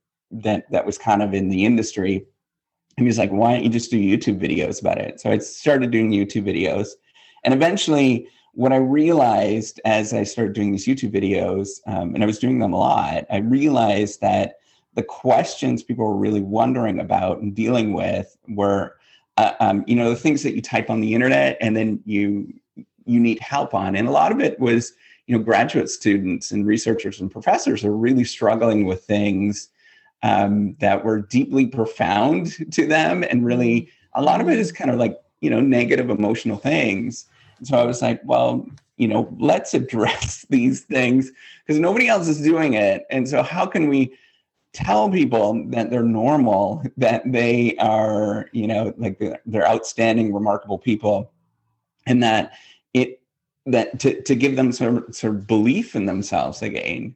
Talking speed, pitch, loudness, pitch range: 185 wpm, 115 Hz, -20 LUFS, 105-130 Hz